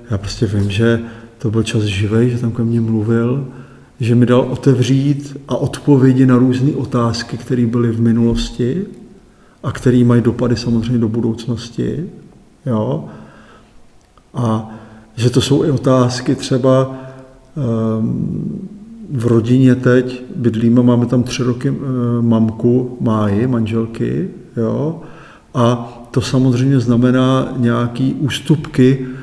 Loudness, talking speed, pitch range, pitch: -15 LUFS, 120 wpm, 115-130 Hz, 125 Hz